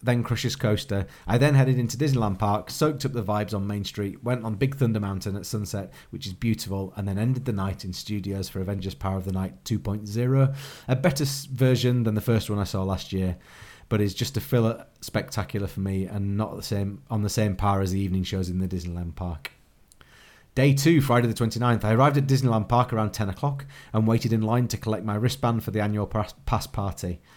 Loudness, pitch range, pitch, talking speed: -26 LUFS, 100-120 Hz, 110 Hz, 220 wpm